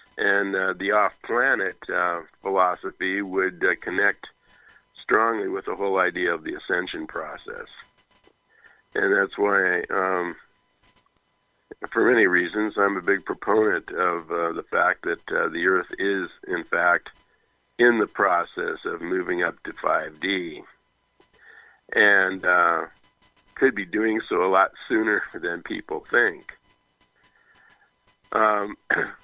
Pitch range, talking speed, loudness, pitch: 95-105 Hz, 130 wpm, -23 LUFS, 95 Hz